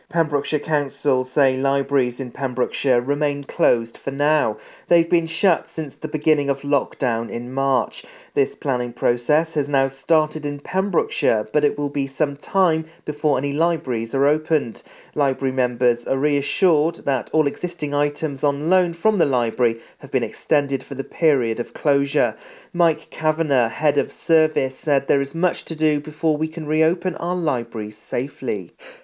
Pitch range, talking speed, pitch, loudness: 135-160 Hz, 160 wpm, 145 Hz, -21 LUFS